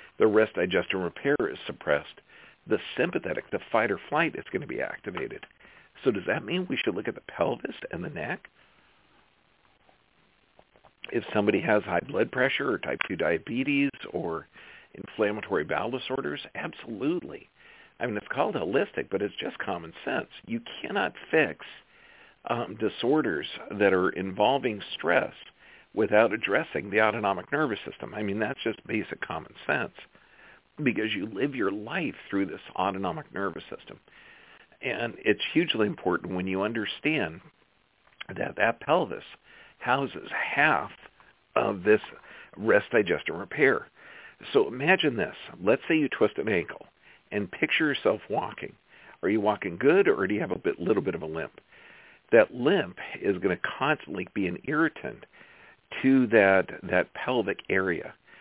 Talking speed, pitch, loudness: 150 wpm, 395 Hz, -28 LUFS